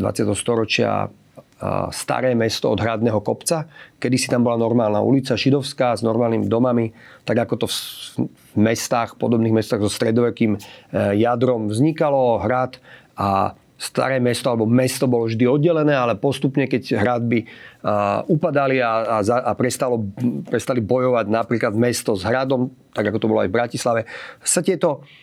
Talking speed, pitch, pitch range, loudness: 145 wpm, 120 Hz, 115-130 Hz, -20 LUFS